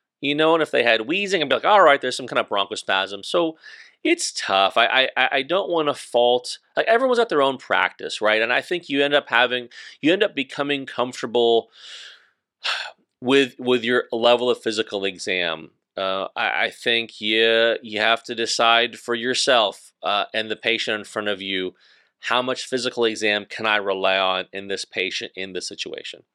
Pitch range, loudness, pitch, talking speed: 110-140 Hz, -21 LUFS, 120 Hz, 200 wpm